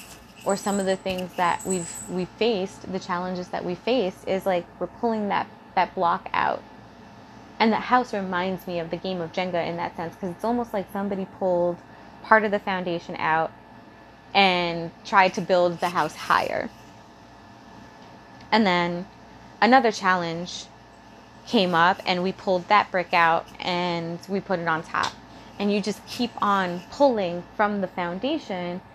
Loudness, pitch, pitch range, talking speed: -24 LUFS, 185 Hz, 170-200 Hz, 165 wpm